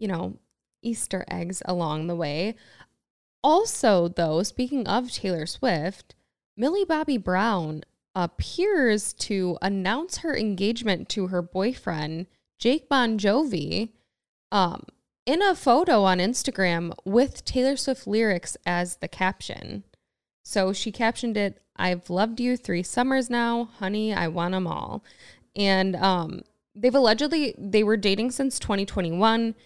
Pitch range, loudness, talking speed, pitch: 185-245 Hz, -25 LUFS, 130 wpm, 210 Hz